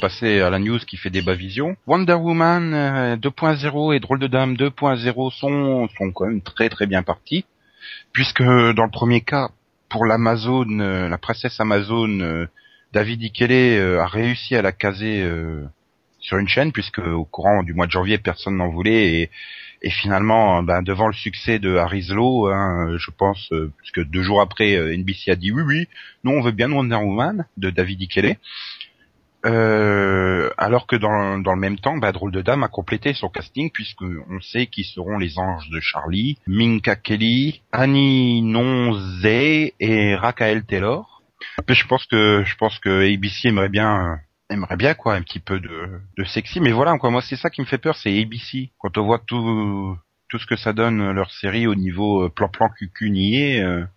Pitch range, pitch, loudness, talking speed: 95-125 Hz, 110 Hz, -19 LUFS, 180 wpm